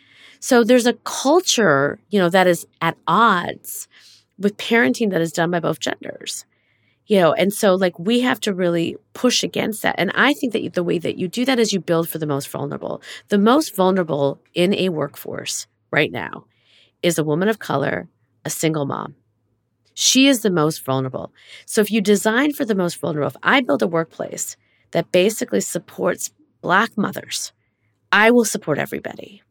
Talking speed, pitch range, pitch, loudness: 185 wpm, 160-225 Hz, 185 Hz, -19 LUFS